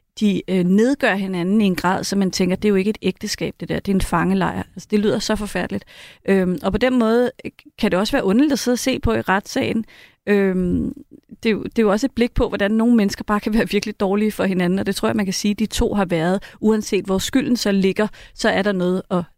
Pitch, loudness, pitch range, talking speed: 205 Hz, -19 LUFS, 190-225 Hz, 260 wpm